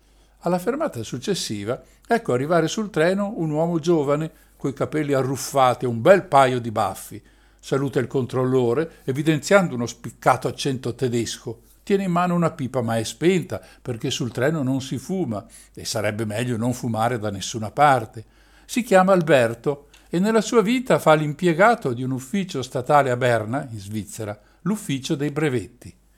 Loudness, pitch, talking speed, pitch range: -22 LUFS, 135 Hz, 160 wpm, 120-165 Hz